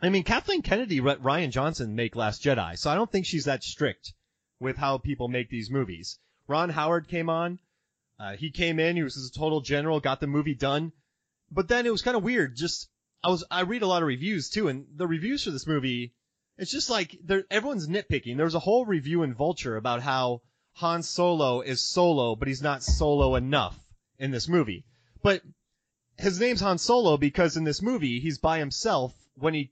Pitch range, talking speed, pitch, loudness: 130-175 Hz, 200 wpm, 150 Hz, -27 LUFS